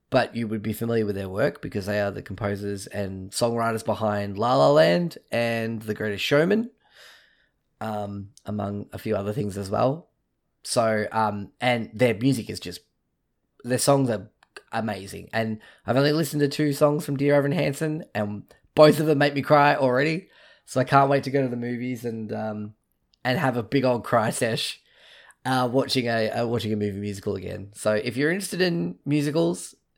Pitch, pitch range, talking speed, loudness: 115 Hz, 105-140 Hz, 190 wpm, -24 LUFS